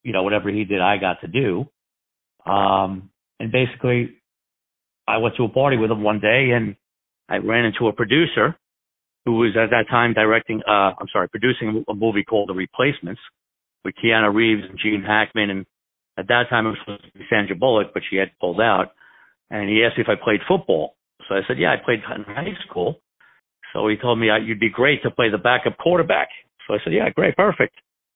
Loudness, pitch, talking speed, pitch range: -20 LUFS, 110 Hz, 205 wpm, 100-115 Hz